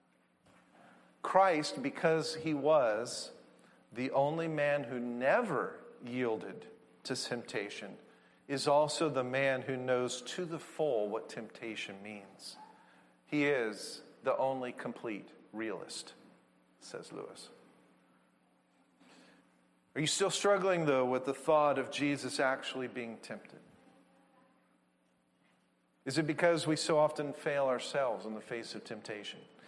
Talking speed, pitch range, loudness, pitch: 115 wpm, 110-155 Hz, -34 LUFS, 135 Hz